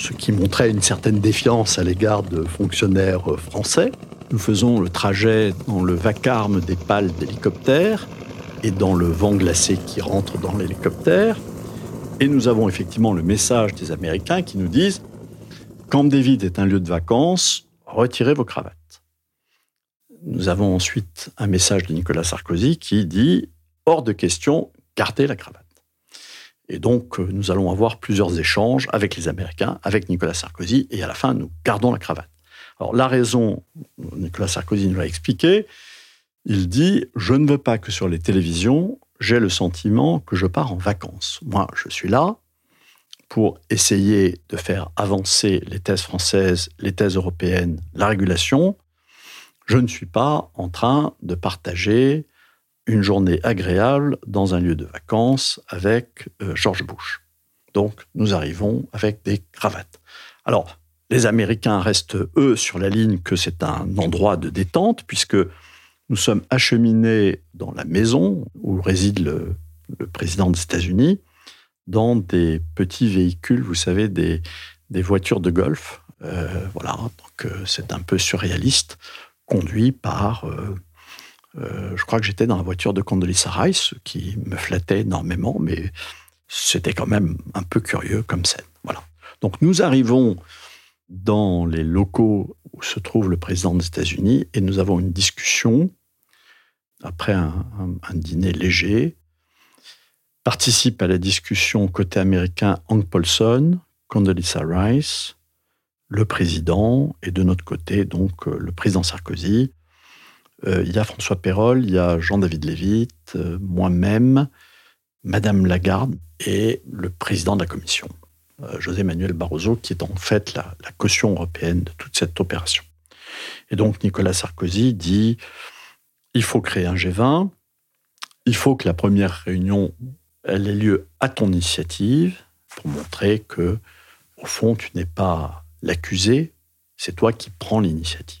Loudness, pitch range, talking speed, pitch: -20 LUFS, 90-110 Hz, 150 wpm, 95 Hz